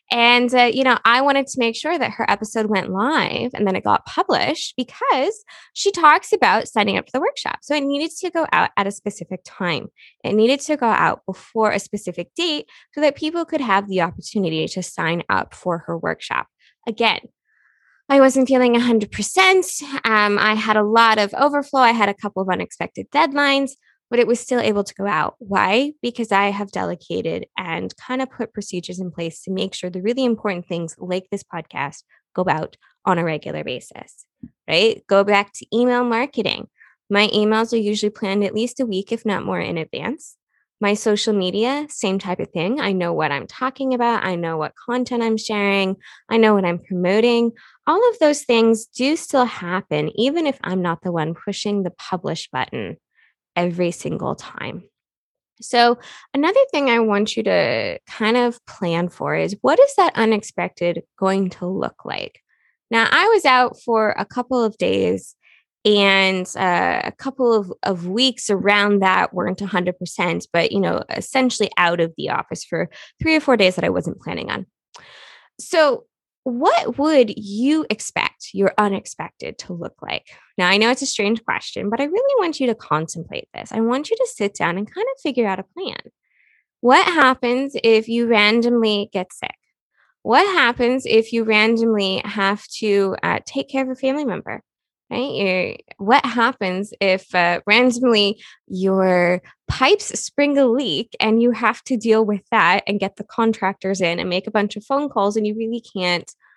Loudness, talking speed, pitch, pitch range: -19 LUFS, 185 wpm, 225 Hz, 195-260 Hz